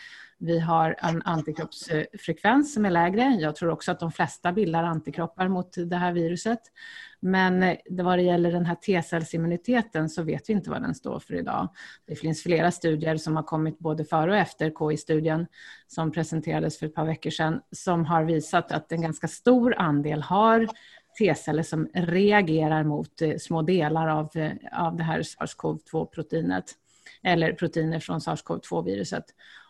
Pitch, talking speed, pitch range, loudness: 165 Hz, 155 wpm, 160-185 Hz, -26 LUFS